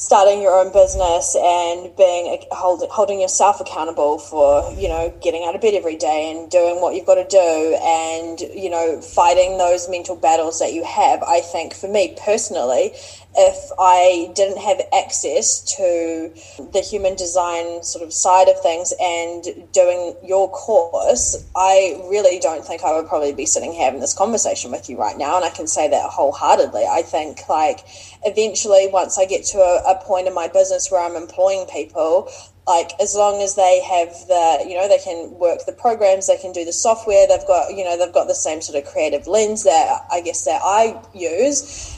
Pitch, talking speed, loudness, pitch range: 185 Hz, 195 wpm, -17 LUFS, 170-215 Hz